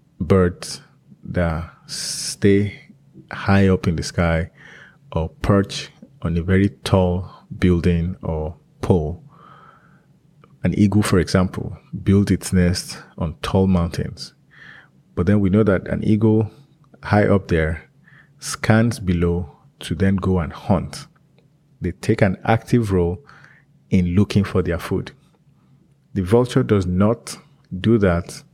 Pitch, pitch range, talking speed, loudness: 95 Hz, 90-110 Hz, 125 wpm, -20 LUFS